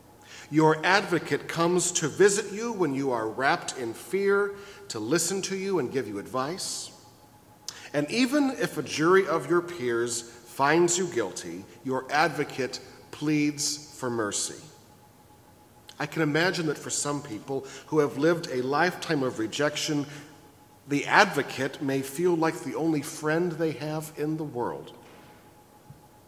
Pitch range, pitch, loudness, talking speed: 125-170 Hz, 145 Hz, -27 LUFS, 145 wpm